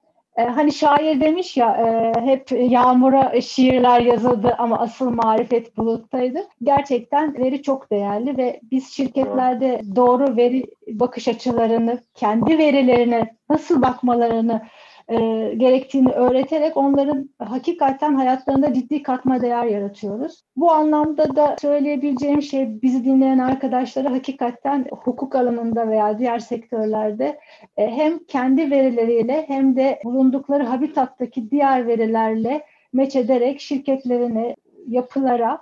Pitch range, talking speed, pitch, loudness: 235-280 Hz, 105 wpm, 255 Hz, -19 LUFS